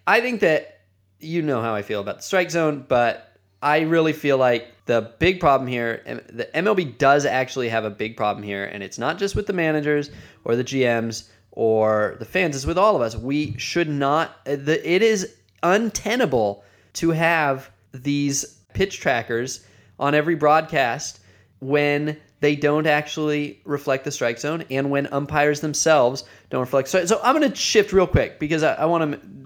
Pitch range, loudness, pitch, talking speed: 115-155 Hz, -21 LUFS, 140 Hz, 185 wpm